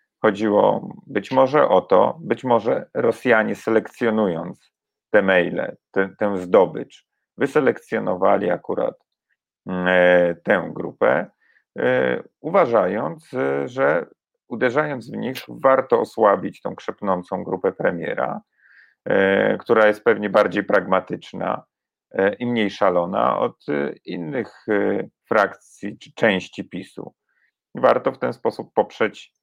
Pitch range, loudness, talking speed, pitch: 90-105 Hz, -20 LUFS, 110 wpm, 95 Hz